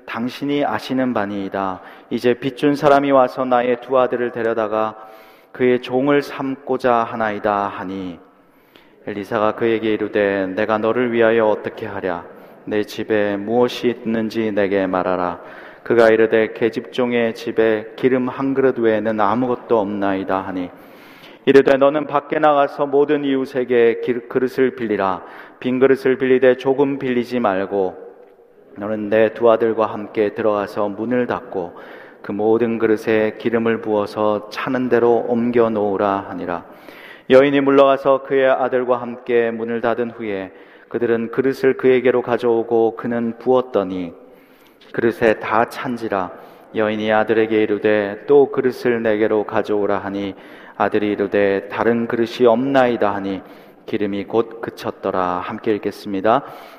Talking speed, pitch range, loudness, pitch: 300 characters per minute, 105-125 Hz, -18 LUFS, 115 Hz